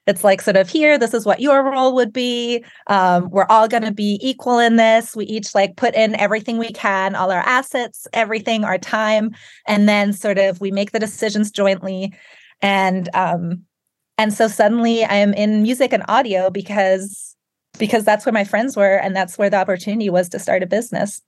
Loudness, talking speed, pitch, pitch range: -17 LUFS, 205 wpm, 210 Hz, 195-225 Hz